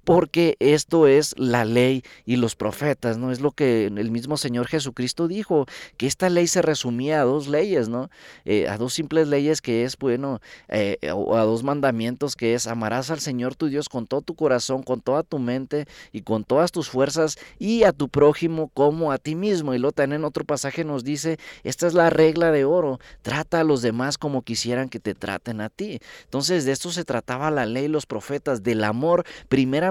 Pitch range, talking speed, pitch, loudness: 125-155 Hz, 210 wpm, 140 Hz, -23 LUFS